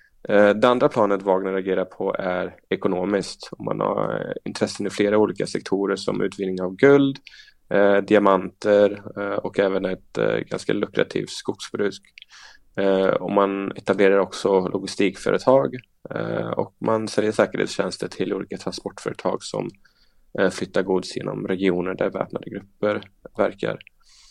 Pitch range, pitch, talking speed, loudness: 95-105 Hz, 100 Hz, 130 wpm, -22 LUFS